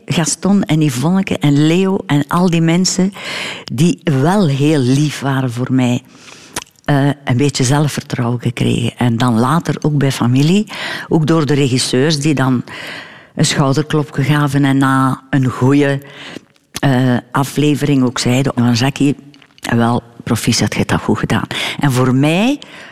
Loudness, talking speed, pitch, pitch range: -14 LUFS, 140 wpm, 140 Hz, 130-155 Hz